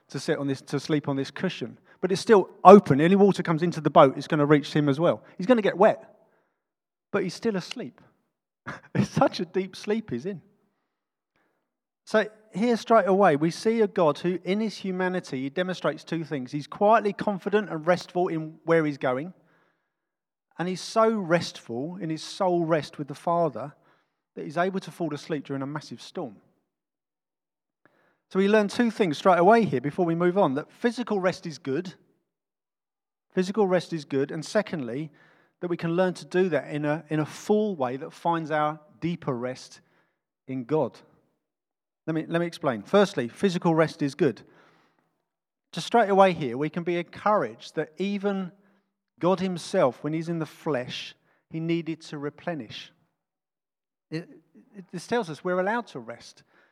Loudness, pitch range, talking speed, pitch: -25 LUFS, 150-195 Hz, 180 wpm, 170 Hz